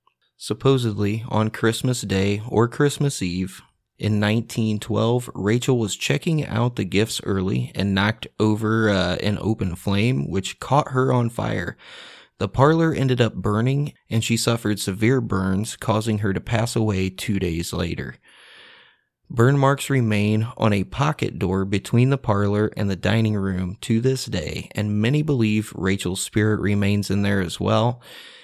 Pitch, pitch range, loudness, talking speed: 110 Hz, 100-120 Hz, -22 LUFS, 155 wpm